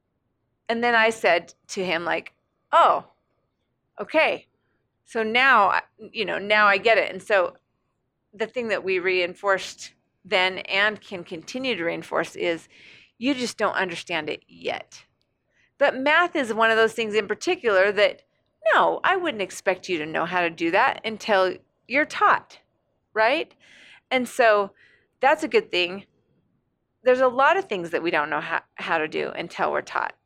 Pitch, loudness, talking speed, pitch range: 210 Hz, -22 LUFS, 165 wpm, 185-255 Hz